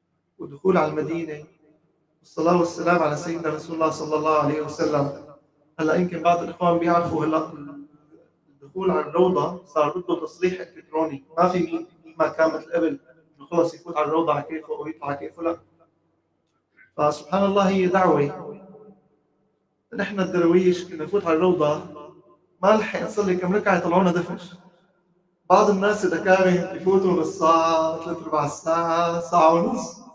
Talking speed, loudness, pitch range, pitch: 140 wpm, -22 LUFS, 155-180 Hz, 165 Hz